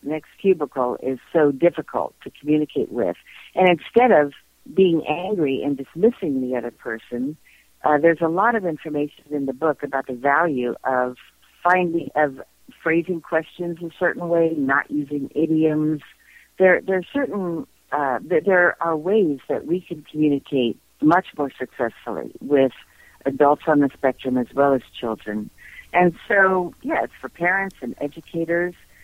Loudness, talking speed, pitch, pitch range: -21 LUFS, 155 wpm, 155 Hz, 135-175 Hz